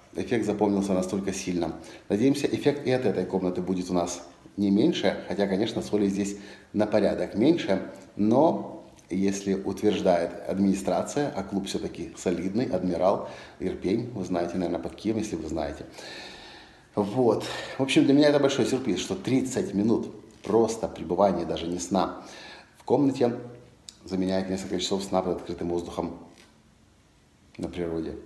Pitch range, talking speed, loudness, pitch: 90-105 Hz, 140 wpm, -27 LUFS, 95 Hz